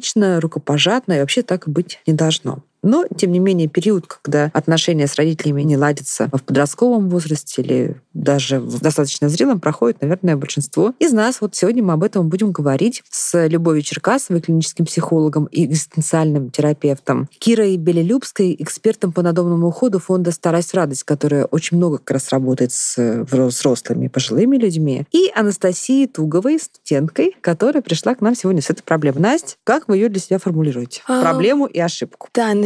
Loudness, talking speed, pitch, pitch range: -17 LUFS, 160 wpm, 170 Hz, 150-195 Hz